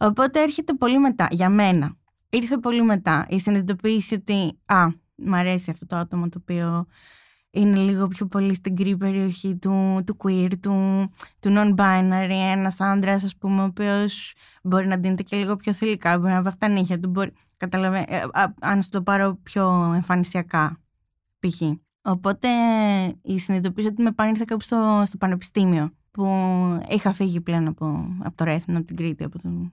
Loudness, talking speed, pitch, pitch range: -22 LUFS, 165 wpm, 190 Hz, 180-205 Hz